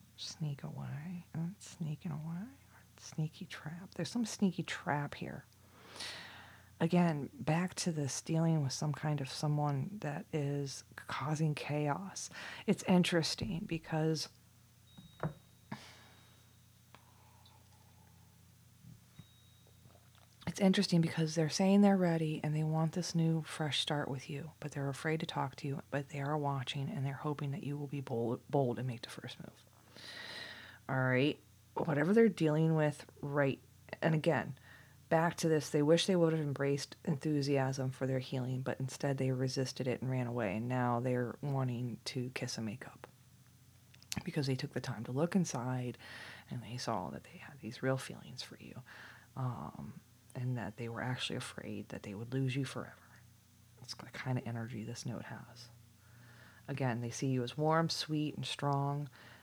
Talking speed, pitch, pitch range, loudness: 160 wpm, 135 Hz, 120-155 Hz, -36 LUFS